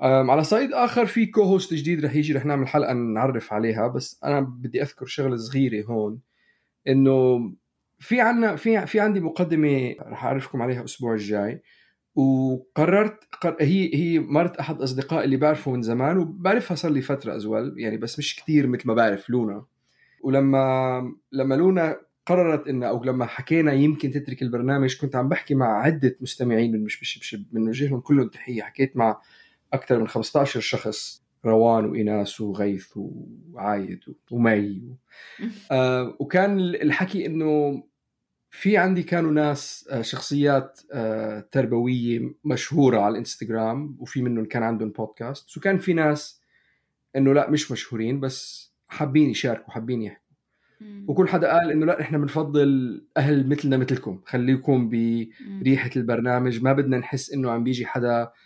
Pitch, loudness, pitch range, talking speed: 135 Hz, -23 LUFS, 120-155 Hz, 140 wpm